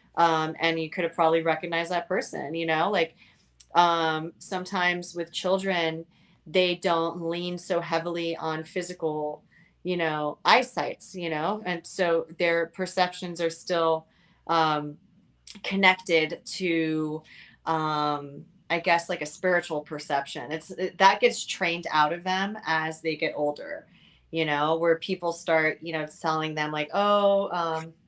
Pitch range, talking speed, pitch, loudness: 160-180 Hz, 145 wpm, 165 Hz, -26 LUFS